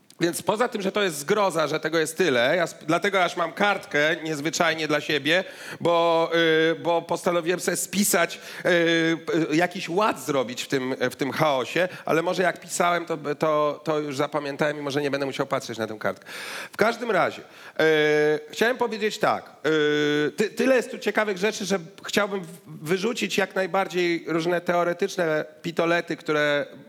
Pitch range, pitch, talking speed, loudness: 150-190 Hz, 170 Hz, 170 wpm, -24 LUFS